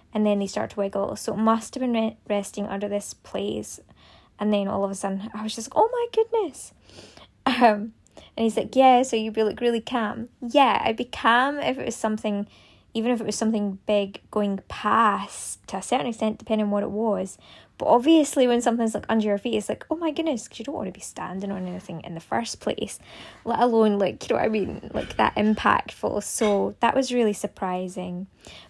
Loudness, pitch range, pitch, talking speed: -24 LUFS, 205-240 Hz, 220 Hz, 225 wpm